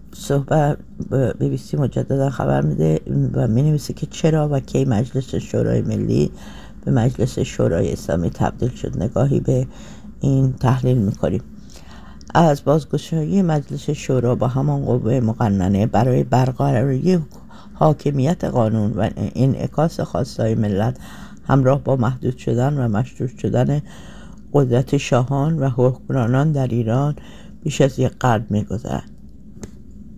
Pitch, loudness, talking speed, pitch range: 130 Hz, -19 LUFS, 130 wpm, 120-145 Hz